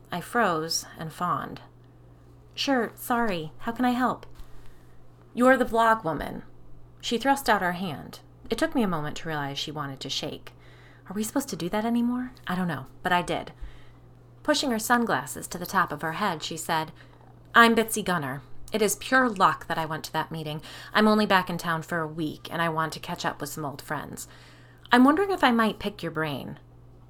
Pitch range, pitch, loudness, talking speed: 150-225 Hz, 170 Hz, -26 LUFS, 205 wpm